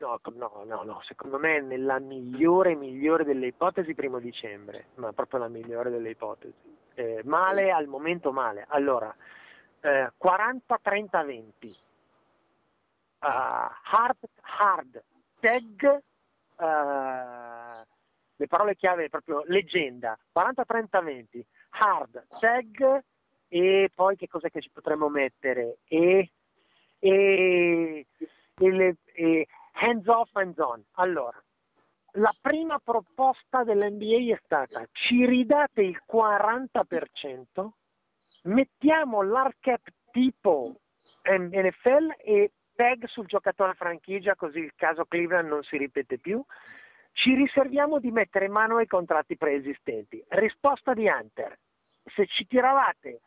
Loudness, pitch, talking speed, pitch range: -26 LUFS, 190 Hz, 115 wpm, 155-240 Hz